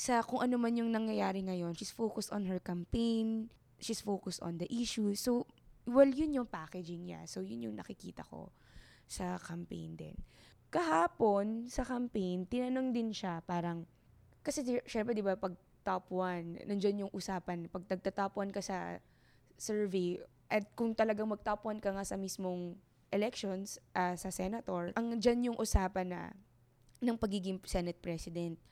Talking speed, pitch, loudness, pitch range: 155 wpm, 195 Hz, -37 LUFS, 180-225 Hz